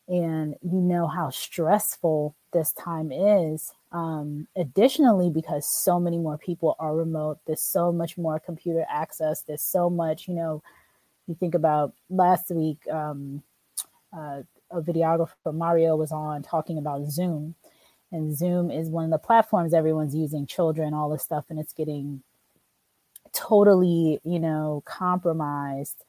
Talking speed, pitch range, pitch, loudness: 145 wpm, 155-175 Hz, 160 Hz, -25 LUFS